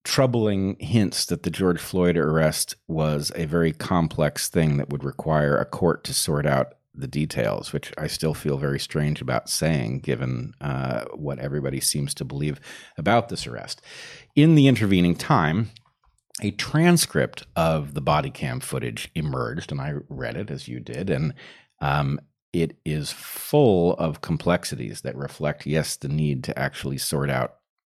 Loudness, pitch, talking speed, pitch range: -24 LUFS, 75 Hz, 160 wpm, 70-90 Hz